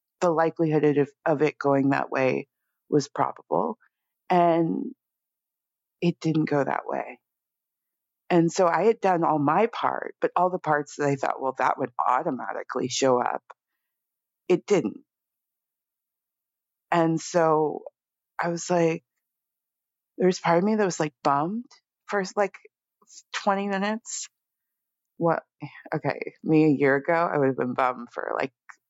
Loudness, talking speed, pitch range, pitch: -25 LUFS, 145 wpm, 145-185 Hz, 165 Hz